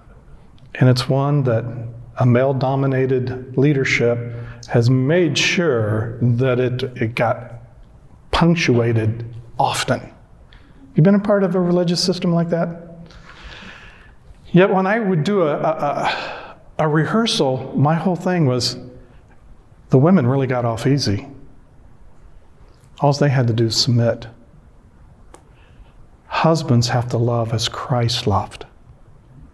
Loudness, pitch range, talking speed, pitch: -18 LUFS, 120-160 Hz, 125 wpm, 130 Hz